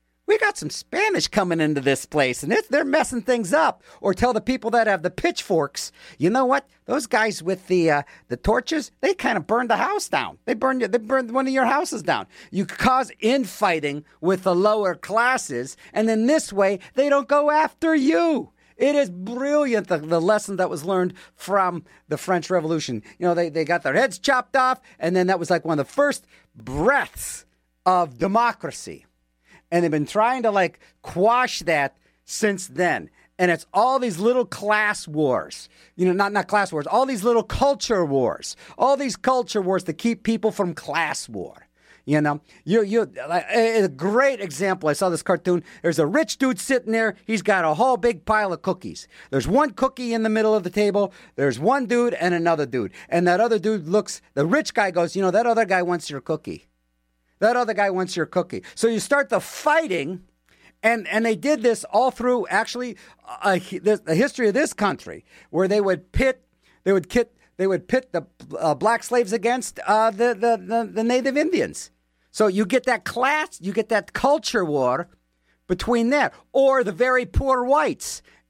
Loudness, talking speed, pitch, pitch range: -22 LUFS, 195 wpm, 210 Hz, 175-250 Hz